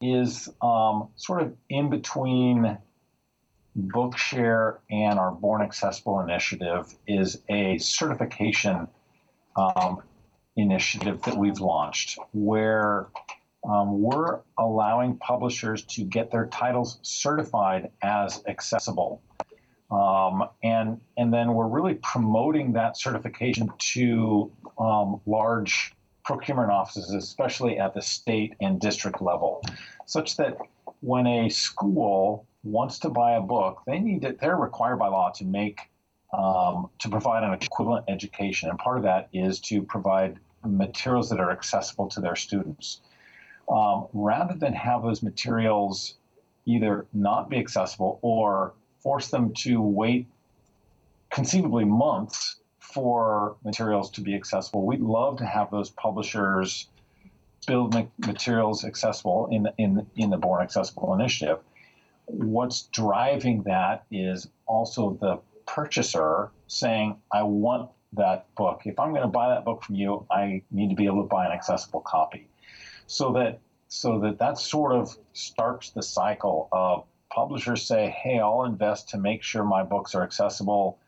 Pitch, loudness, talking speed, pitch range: 110 Hz, -26 LUFS, 135 wpm, 100-120 Hz